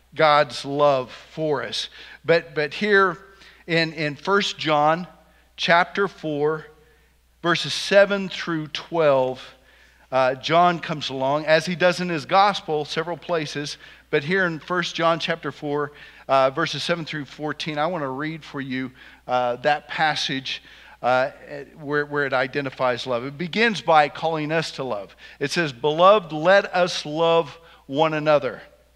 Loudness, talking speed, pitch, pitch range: -22 LUFS, 145 wpm, 155 Hz, 145-170 Hz